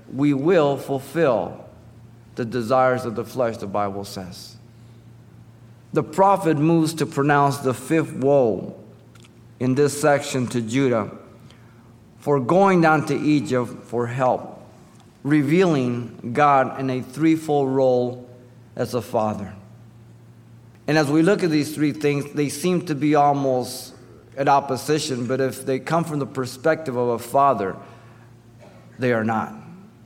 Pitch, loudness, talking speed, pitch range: 130 Hz, -21 LUFS, 135 wpm, 115-145 Hz